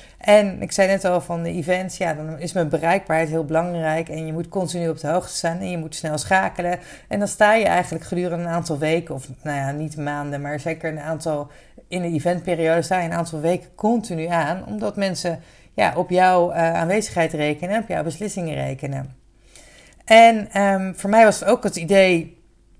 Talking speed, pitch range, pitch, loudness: 205 wpm, 160-185 Hz, 170 Hz, -20 LUFS